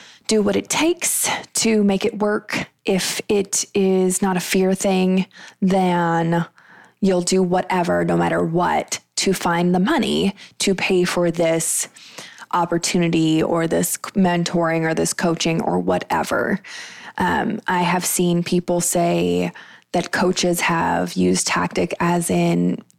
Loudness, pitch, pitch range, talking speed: -19 LUFS, 180 Hz, 165-195 Hz, 135 wpm